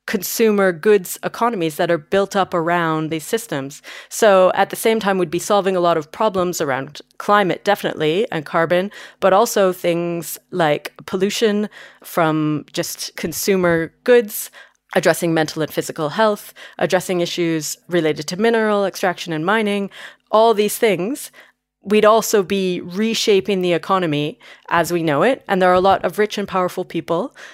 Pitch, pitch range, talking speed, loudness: 185 Hz, 170-210 Hz, 155 wpm, -18 LUFS